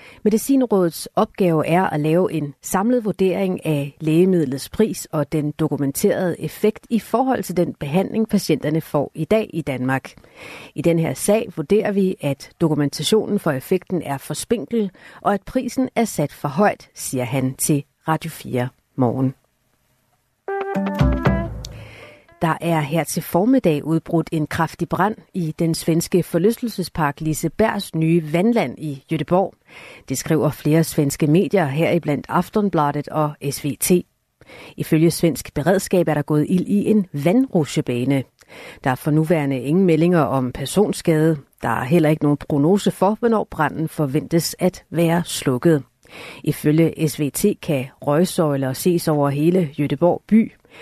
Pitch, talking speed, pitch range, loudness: 165 Hz, 140 wpm, 150-190 Hz, -20 LUFS